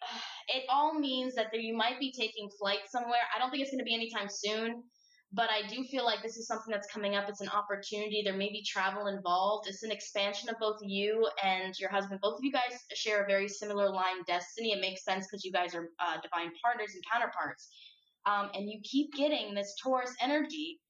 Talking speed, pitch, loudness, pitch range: 225 wpm, 210 Hz, -34 LUFS, 200-240 Hz